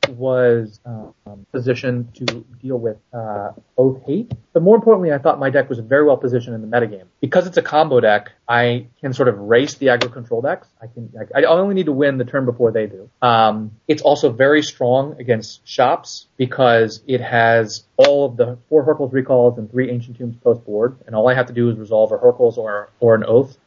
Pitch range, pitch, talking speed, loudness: 115-135 Hz, 125 Hz, 220 wpm, -17 LUFS